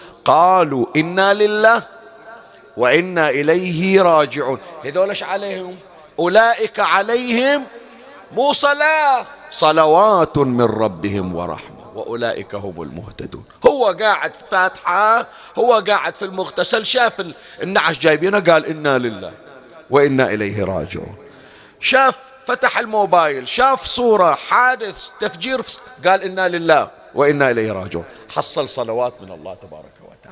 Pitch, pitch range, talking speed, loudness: 185 Hz, 140-225 Hz, 105 wpm, -15 LUFS